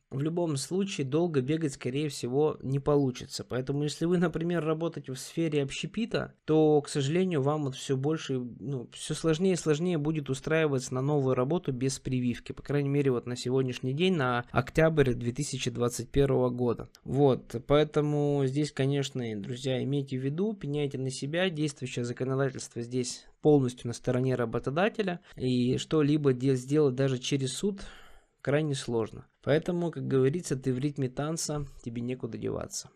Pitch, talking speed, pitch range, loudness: 140 Hz, 150 wpm, 130-155 Hz, -30 LUFS